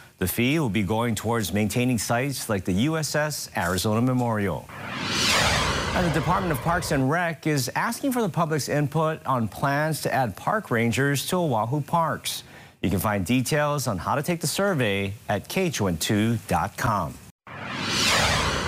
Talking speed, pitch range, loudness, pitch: 150 wpm, 110-155 Hz, -24 LUFS, 130 Hz